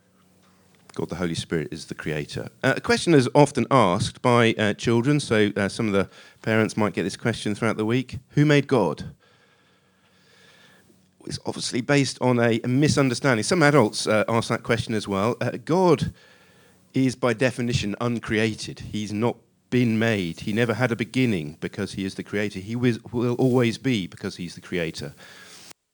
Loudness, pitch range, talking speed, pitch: -23 LUFS, 105-125 Hz, 175 wpm, 115 Hz